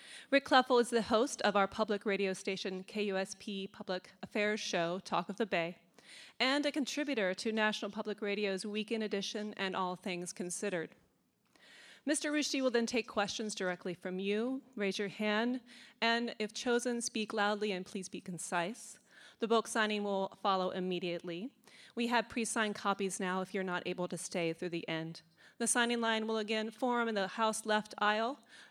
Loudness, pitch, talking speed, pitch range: -35 LUFS, 210 Hz, 175 wpm, 190-230 Hz